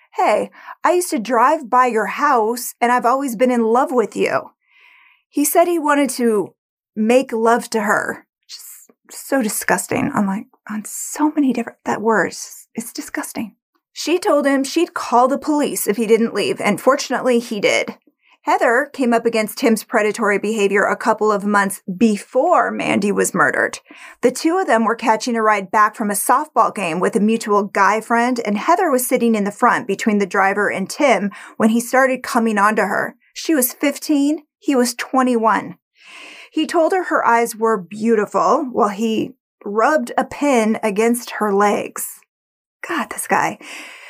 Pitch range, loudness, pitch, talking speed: 215-280 Hz, -17 LUFS, 235 Hz, 175 wpm